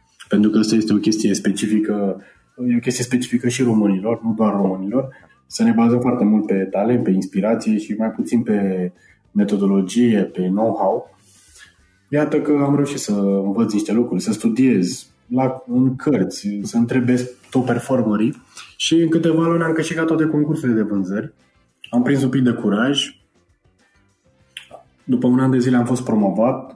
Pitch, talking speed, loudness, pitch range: 115 Hz, 160 wpm, -18 LUFS, 105-130 Hz